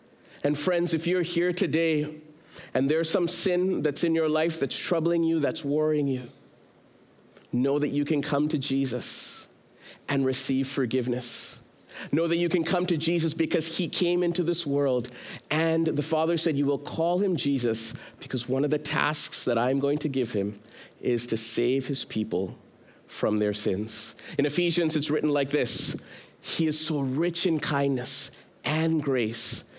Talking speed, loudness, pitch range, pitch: 170 wpm, -26 LUFS, 130-165 Hz, 150 Hz